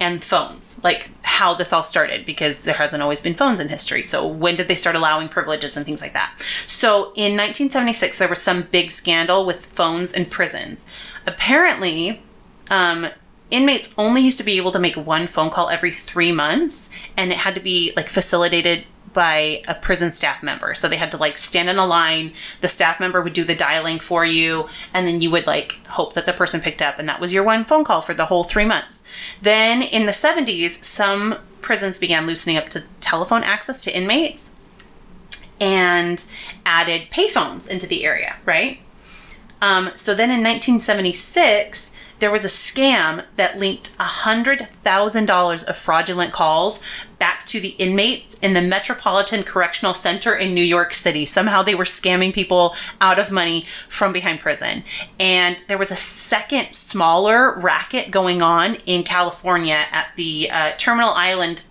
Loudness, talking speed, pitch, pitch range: -17 LUFS, 180 wpm, 185 Hz, 170-210 Hz